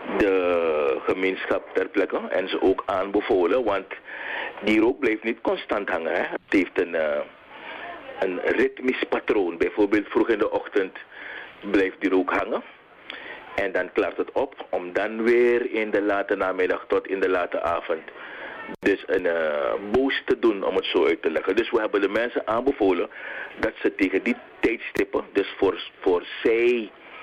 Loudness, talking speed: -24 LUFS, 170 wpm